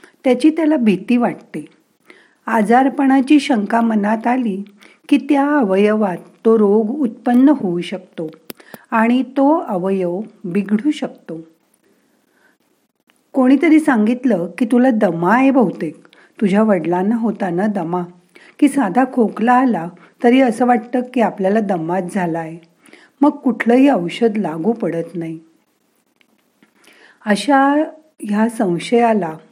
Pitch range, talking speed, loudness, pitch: 185-260 Hz, 110 wpm, -16 LUFS, 225 Hz